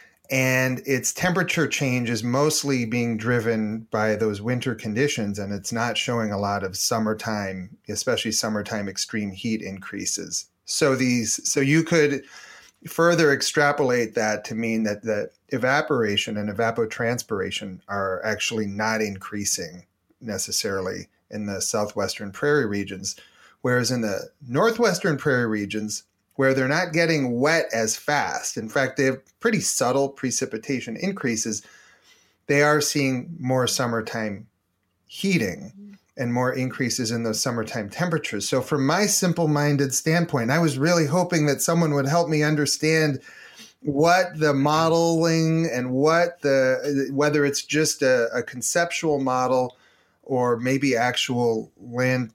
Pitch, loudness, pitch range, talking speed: 130 Hz, -23 LUFS, 110-150 Hz, 135 wpm